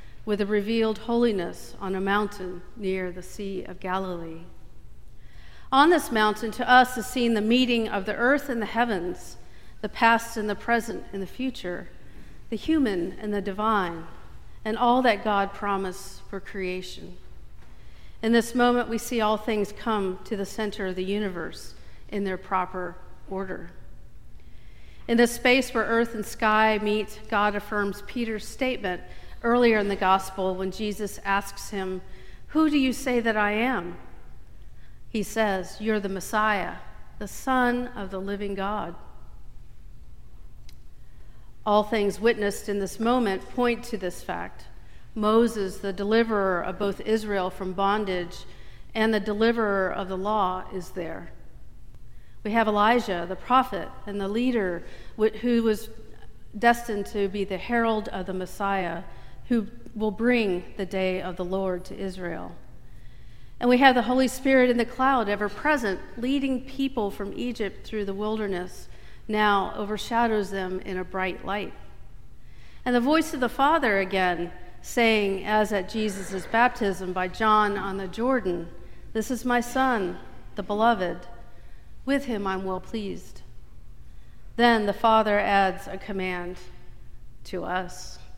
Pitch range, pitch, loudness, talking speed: 190-230 Hz, 205 Hz, -26 LUFS, 150 wpm